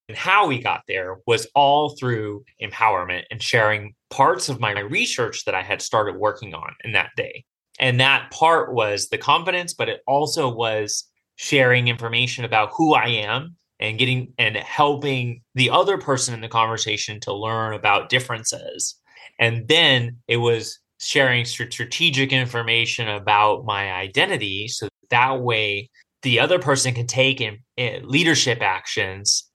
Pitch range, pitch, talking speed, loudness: 115-140 Hz, 120 Hz, 150 wpm, -20 LUFS